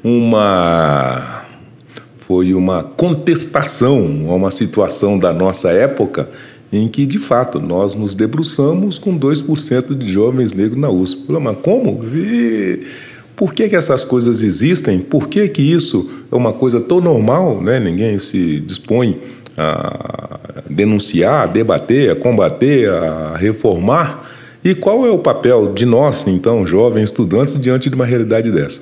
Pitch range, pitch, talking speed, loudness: 100-145 Hz, 115 Hz, 145 wpm, -14 LUFS